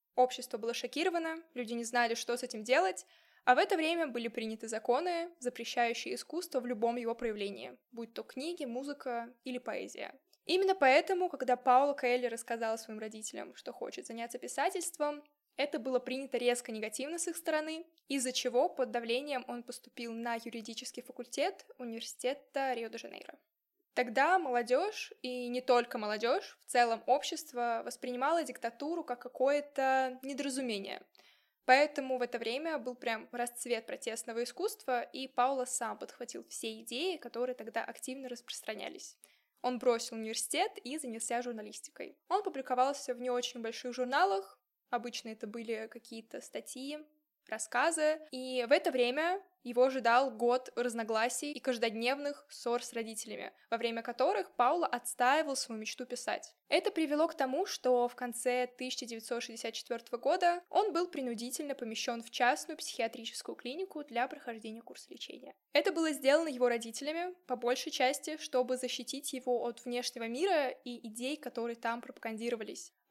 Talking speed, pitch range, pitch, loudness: 145 wpm, 235-290 Hz, 250 Hz, -35 LUFS